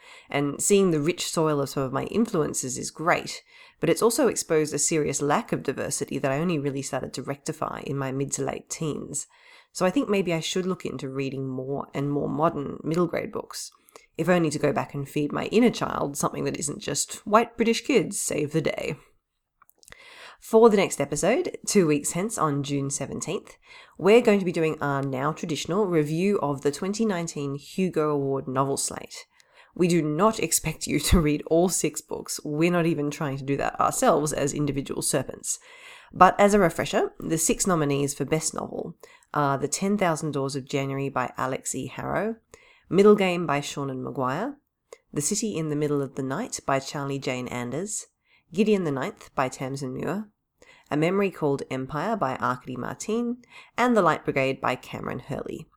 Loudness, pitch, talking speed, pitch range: -25 LUFS, 155 Hz, 190 wpm, 140-210 Hz